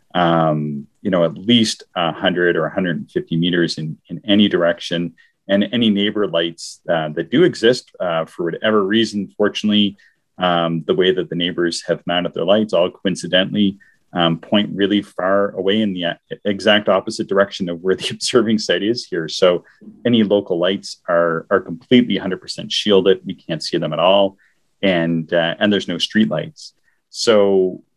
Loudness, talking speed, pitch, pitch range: -18 LUFS, 170 wpm, 95 Hz, 85-105 Hz